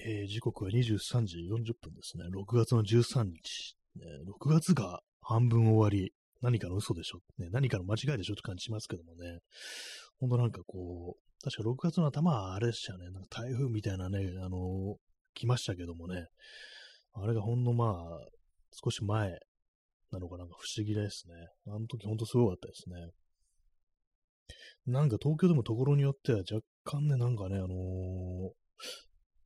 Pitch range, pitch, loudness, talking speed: 90-120 Hz, 110 Hz, -33 LUFS, 300 characters per minute